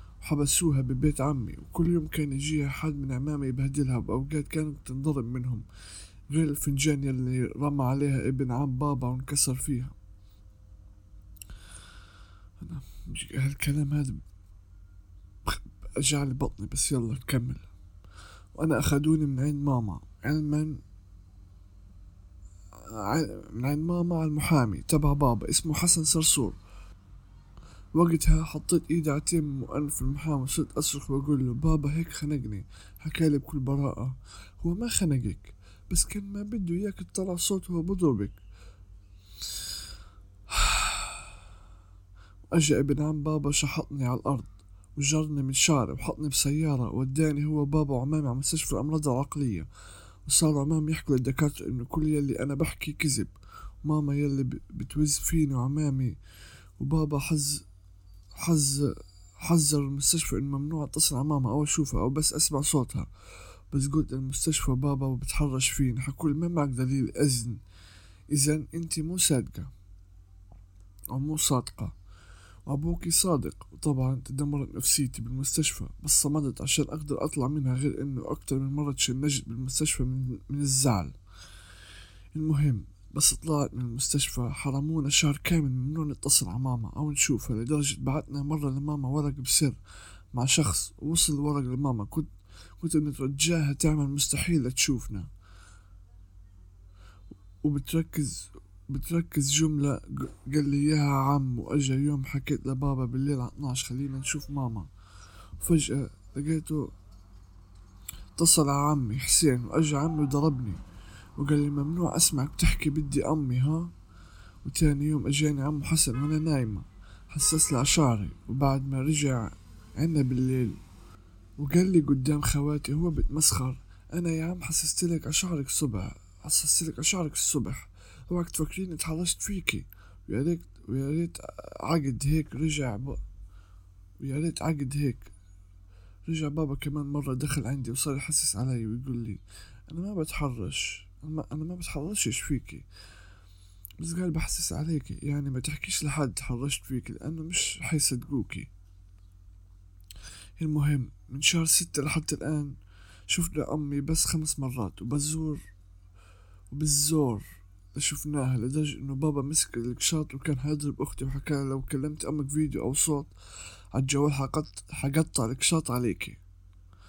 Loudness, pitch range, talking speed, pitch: -28 LUFS, 95-150 Hz, 125 wpm, 135 Hz